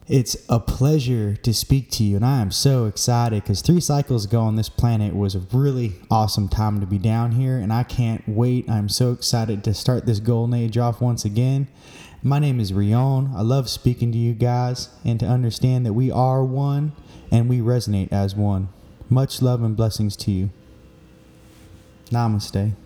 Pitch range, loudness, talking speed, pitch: 105-125 Hz, -21 LUFS, 190 wpm, 120 Hz